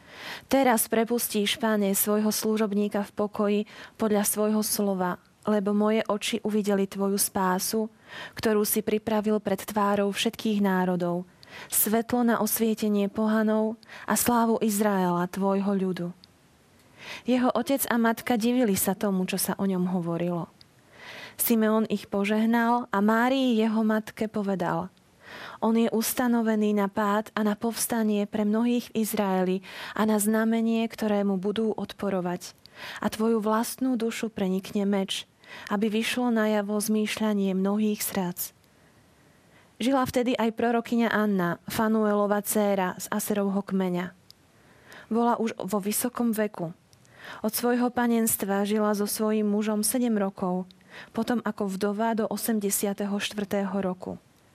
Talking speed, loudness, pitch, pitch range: 125 wpm, -26 LUFS, 210 Hz, 200-225 Hz